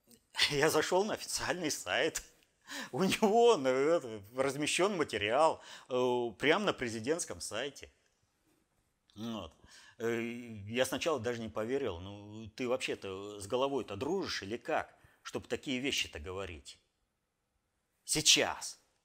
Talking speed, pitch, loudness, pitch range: 105 wpm, 120 Hz, -33 LUFS, 110-135 Hz